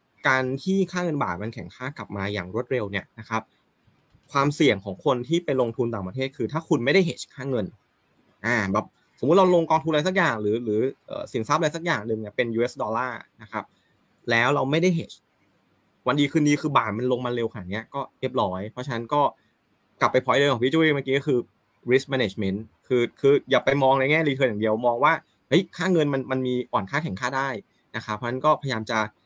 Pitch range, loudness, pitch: 110-145 Hz, -24 LUFS, 130 Hz